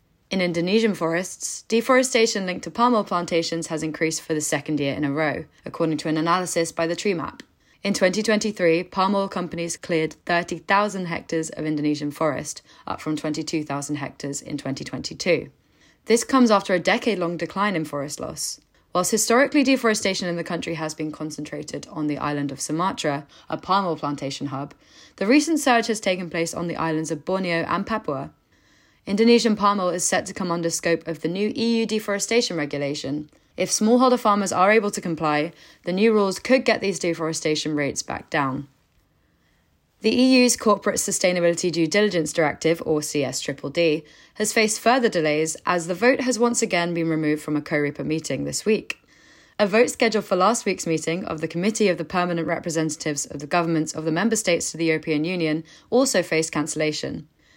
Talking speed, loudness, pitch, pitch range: 180 wpm, -22 LUFS, 170 Hz, 155-205 Hz